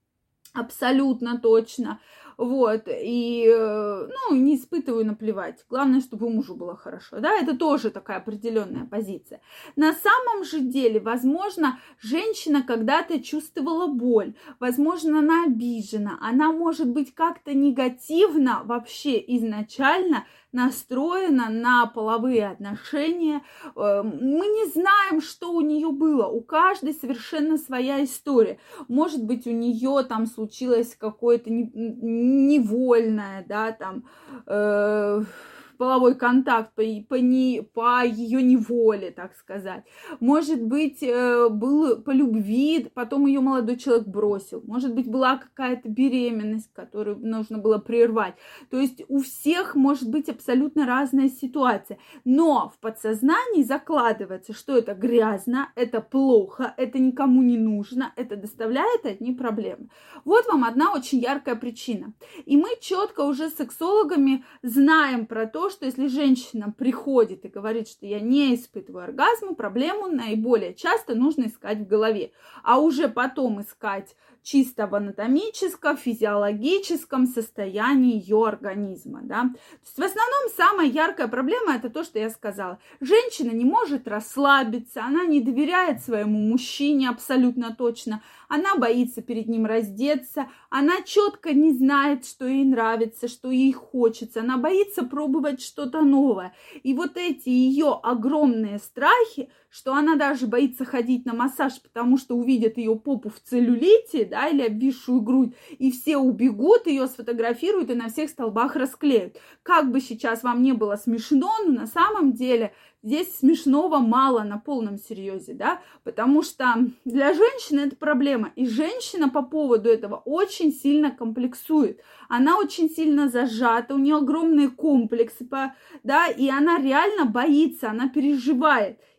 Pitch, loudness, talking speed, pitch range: 260 Hz, -23 LUFS, 135 wpm, 230-295 Hz